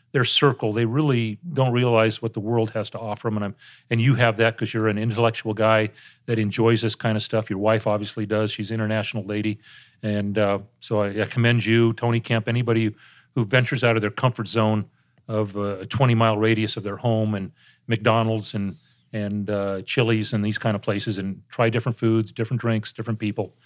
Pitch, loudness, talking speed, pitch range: 110 Hz, -23 LUFS, 200 wpm, 105-115 Hz